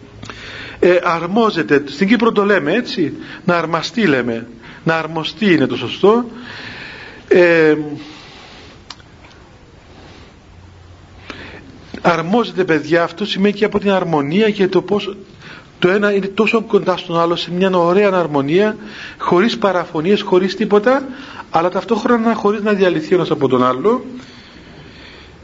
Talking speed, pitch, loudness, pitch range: 120 wpm, 180 Hz, -15 LUFS, 150-205 Hz